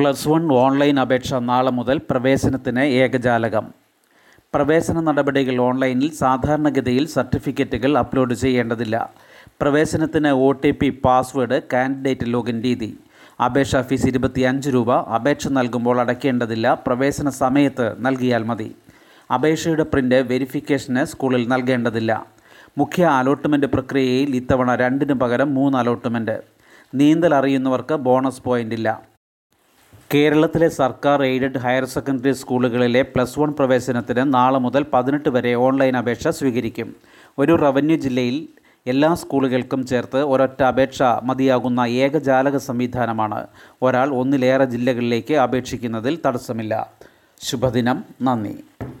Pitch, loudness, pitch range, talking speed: 130 Hz, -19 LUFS, 125-140 Hz, 105 wpm